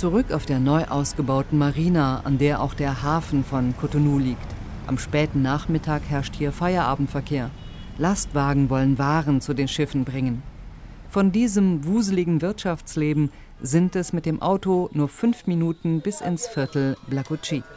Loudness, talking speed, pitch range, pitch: -23 LUFS, 145 wpm, 135-170 Hz, 145 Hz